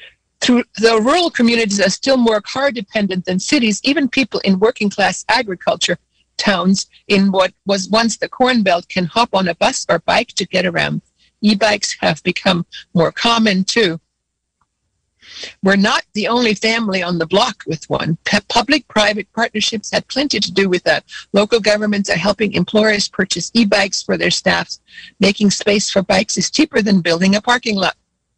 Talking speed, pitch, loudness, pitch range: 170 wpm, 205 Hz, -15 LUFS, 190-230 Hz